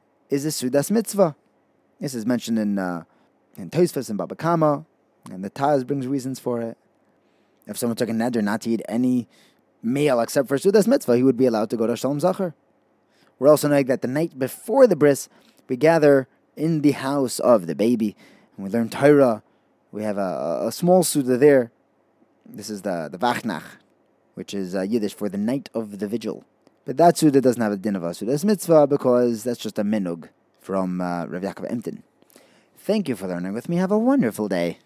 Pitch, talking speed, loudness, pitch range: 125 Hz, 200 wpm, -21 LUFS, 105-145 Hz